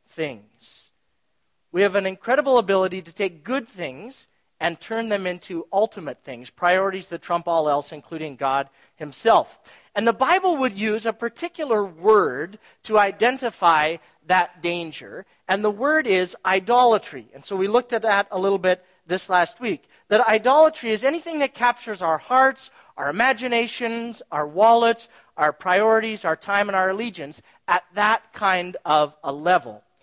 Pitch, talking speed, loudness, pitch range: 195 Hz, 155 wpm, -21 LUFS, 170-230 Hz